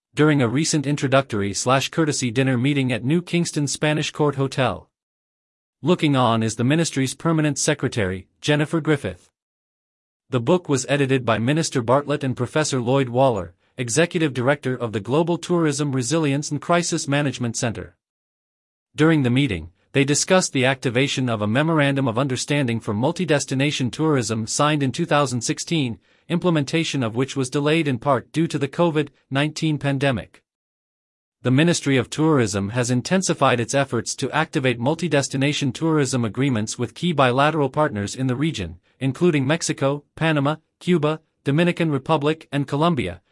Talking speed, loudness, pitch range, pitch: 145 wpm, -21 LUFS, 125-155 Hz, 140 Hz